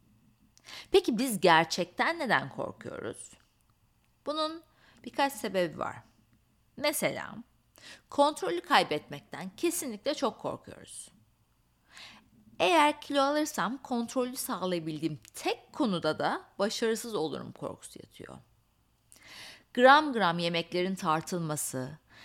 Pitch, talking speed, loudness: 225 Hz, 85 wpm, -29 LUFS